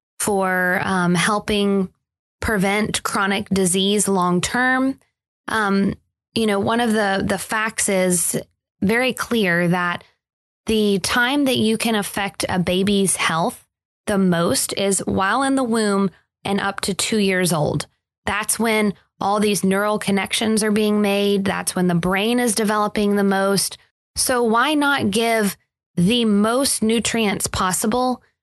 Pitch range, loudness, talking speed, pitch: 195-225 Hz, -19 LUFS, 140 wpm, 205 Hz